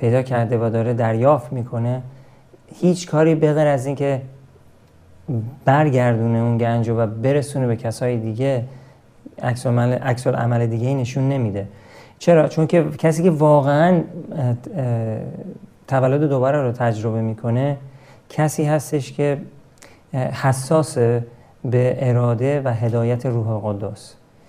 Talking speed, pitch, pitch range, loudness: 115 wpm, 130 Hz, 120-145 Hz, -19 LUFS